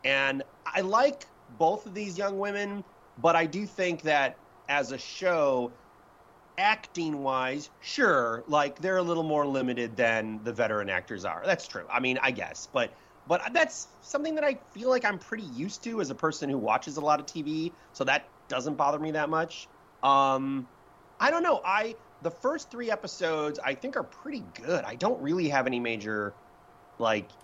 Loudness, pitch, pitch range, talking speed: -29 LUFS, 155 Hz, 135-200 Hz, 185 wpm